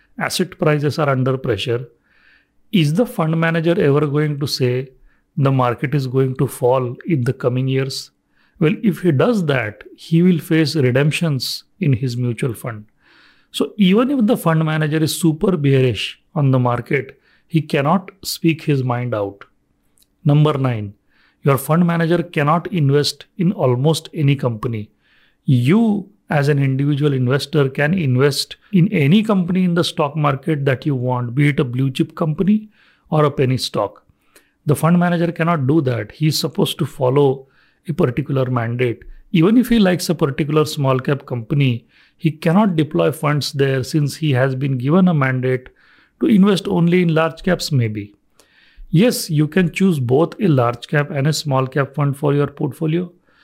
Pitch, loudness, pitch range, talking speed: 150 Hz, -18 LUFS, 130-170 Hz, 170 wpm